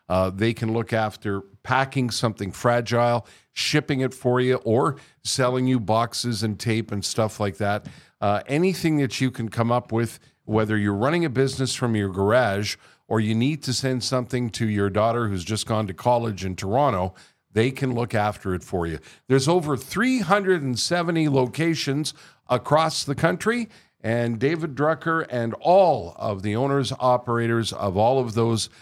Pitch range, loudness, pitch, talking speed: 110-140 Hz, -23 LUFS, 120 Hz, 170 wpm